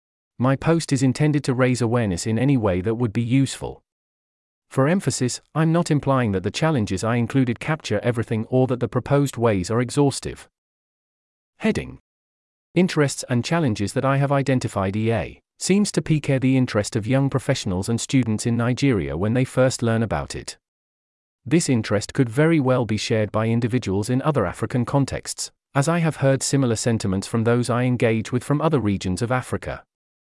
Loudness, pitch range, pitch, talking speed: -22 LUFS, 105-135 Hz, 120 Hz, 175 wpm